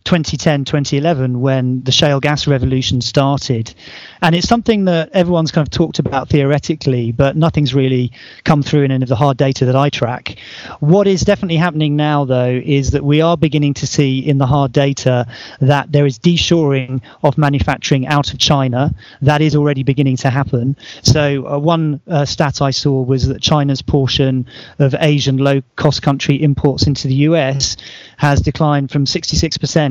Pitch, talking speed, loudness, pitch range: 145 Hz, 175 wpm, -14 LUFS, 135-150 Hz